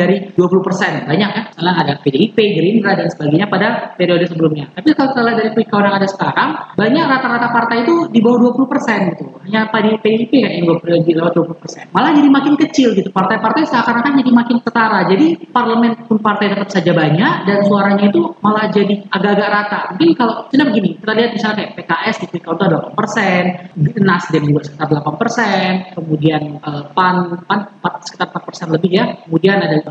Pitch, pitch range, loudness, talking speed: 200 Hz, 175-230 Hz, -14 LUFS, 195 wpm